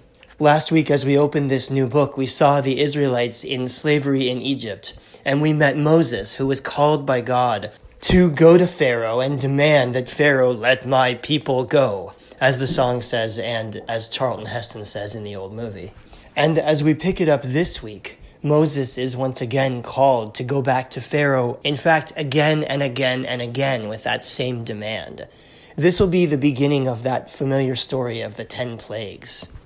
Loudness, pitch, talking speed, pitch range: -19 LUFS, 135 Hz, 185 wpm, 125-145 Hz